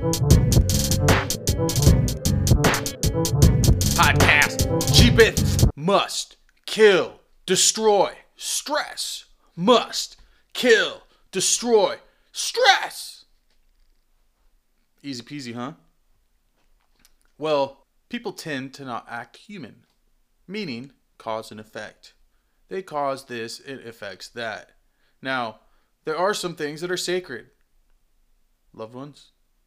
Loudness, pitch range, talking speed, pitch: -21 LUFS, 120-185 Hz, 80 wpm, 140 Hz